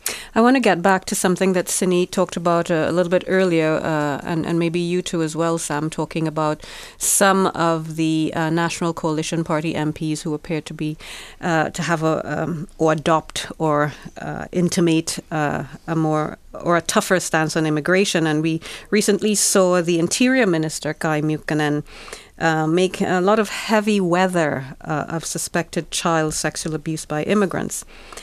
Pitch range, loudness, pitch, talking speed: 155-180 Hz, -20 LUFS, 165 Hz, 175 wpm